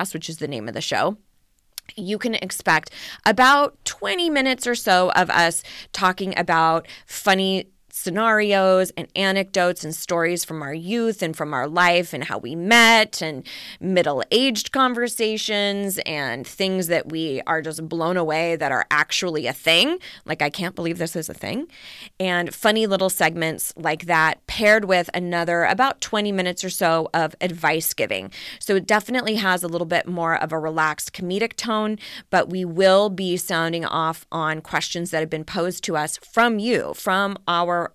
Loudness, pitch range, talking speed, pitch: -21 LUFS, 160-210 Hz, 170 wpm, 180 Hz